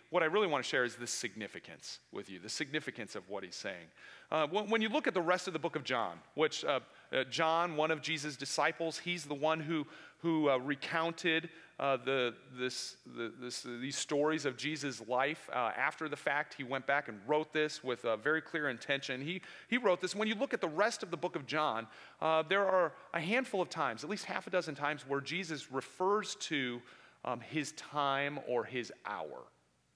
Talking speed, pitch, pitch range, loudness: 215 wpm, 150 Hz, 130-170 Hz, -35 LUFS